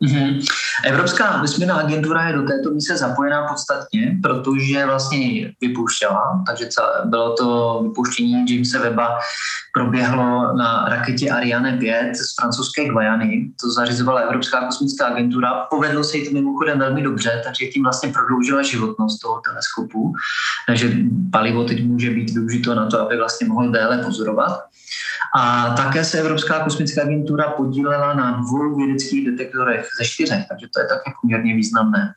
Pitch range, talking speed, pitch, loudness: 120-145 Hz, 150 wpm, 130 Hz, -19 LUFS